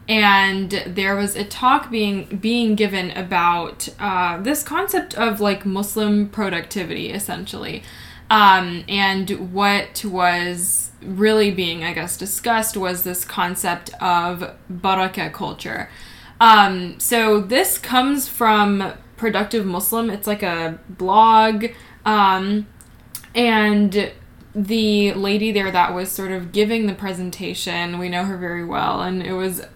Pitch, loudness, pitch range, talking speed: 195 Hz, -19 LUFS, 185-215 Hz, 125 wpm